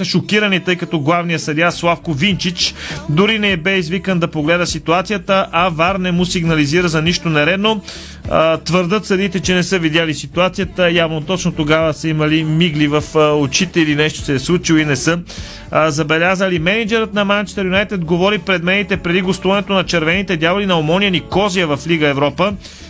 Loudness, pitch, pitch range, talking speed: -15 LUFS, 175 Hz, 160-190 Hz, 170 wpm